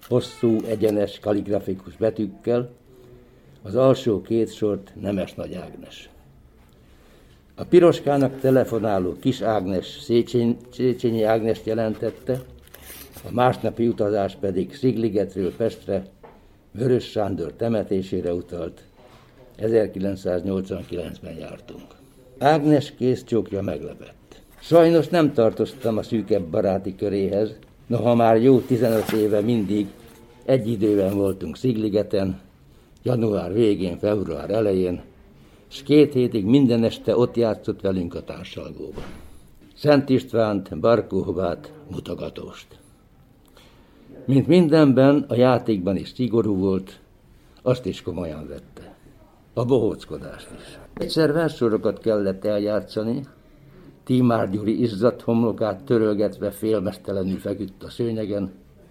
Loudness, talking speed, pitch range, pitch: -22 LUFS, 100 wpm, 100-125 Hz, 110 Hz